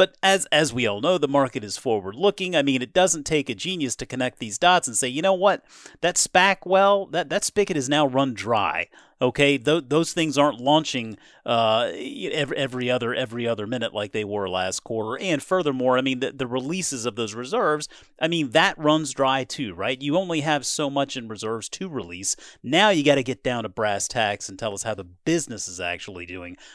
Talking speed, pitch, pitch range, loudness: 220 wpm, 135 Hz, 115-160 Hz, -23 LUFS